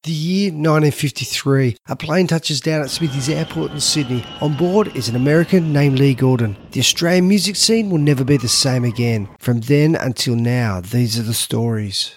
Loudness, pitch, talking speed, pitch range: -17 LUFS, 140 Hz, 195 wpm, 120-160 Hz